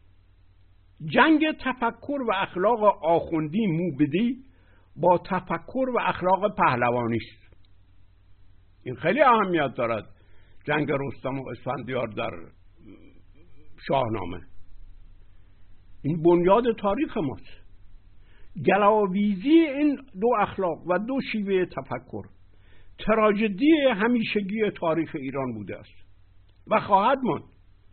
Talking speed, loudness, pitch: 90 wpm, -24 LUFS, 135 Hz